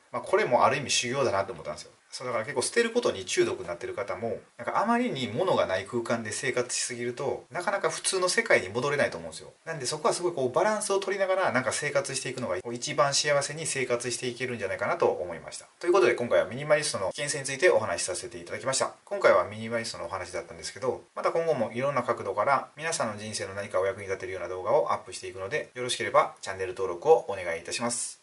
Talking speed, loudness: 560 characters per minute, -28 LUFS